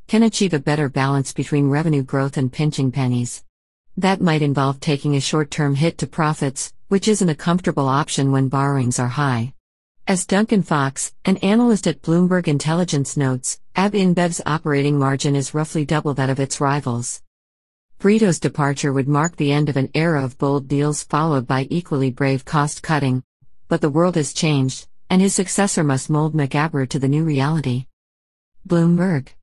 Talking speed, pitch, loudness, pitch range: 165 wpm, 145 Hz, -19 LUFS, 135-165 Hz